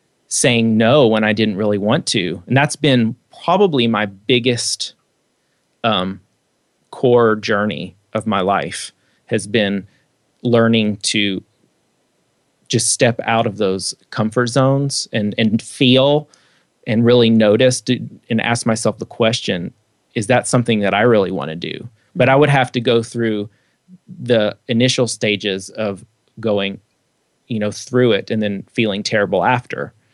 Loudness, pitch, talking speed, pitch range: -17 LUFS, 115 Hz, 145 wpm, 105-125 Hz